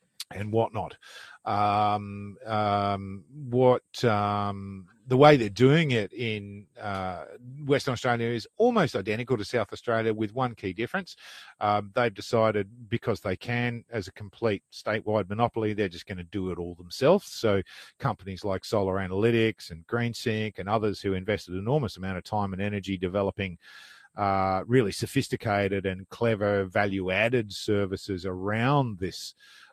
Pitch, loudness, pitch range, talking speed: 105 Hz, -27 LUFS, 95-115 Hz, 145 wpm